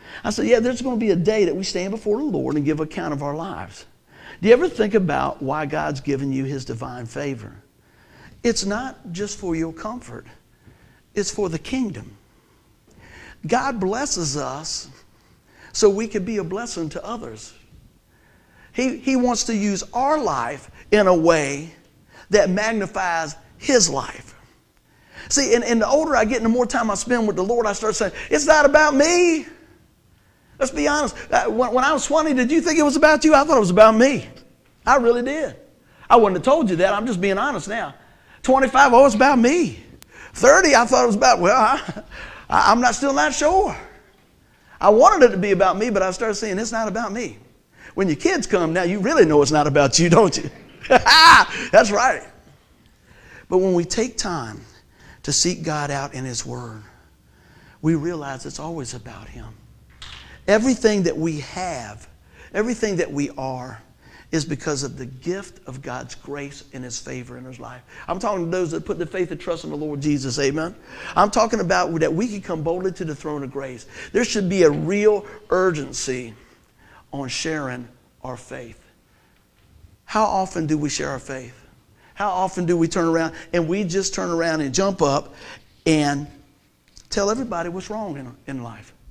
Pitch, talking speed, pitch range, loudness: 185 Hz, 190 wpm, 145-230 Hz, -19 LUFS